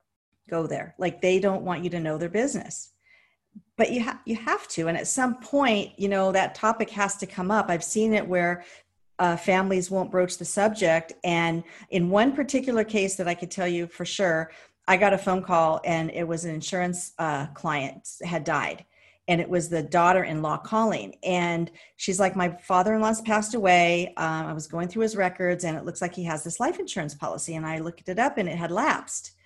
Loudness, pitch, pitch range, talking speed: -26 LUFS, 180 Hz, 170-205 Hz, 210 wpm